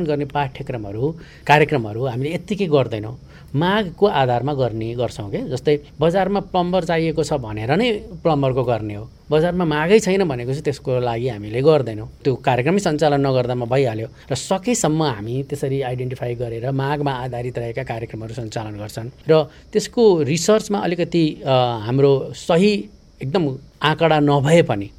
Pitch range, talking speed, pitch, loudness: 125-165 Hz, 135 wpm, 140 Hz, -20 LUFS